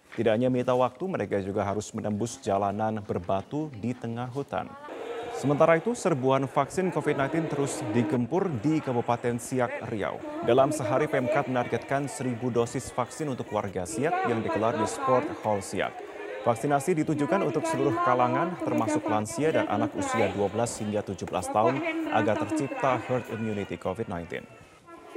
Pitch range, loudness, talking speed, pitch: 105-145 Hz, -28 LUFS, 140 wpm, 125 Hz